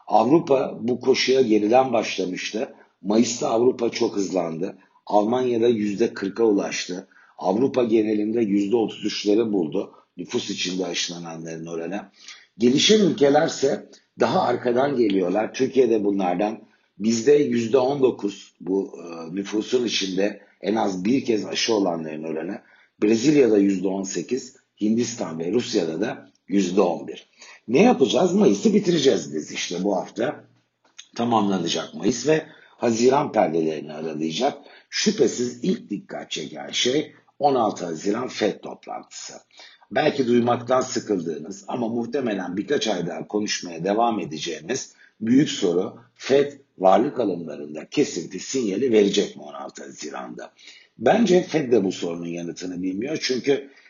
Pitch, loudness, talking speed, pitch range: 110 Hz, -22 LUFS, 110 wpm, 95-125 Hz